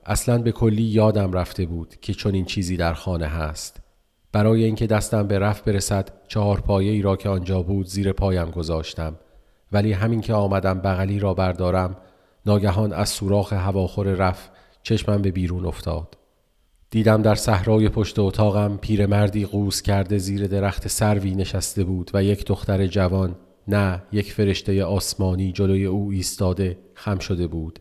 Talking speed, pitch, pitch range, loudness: 155 wpm, 100 Hz, 95-105 Hz, -22 LUFS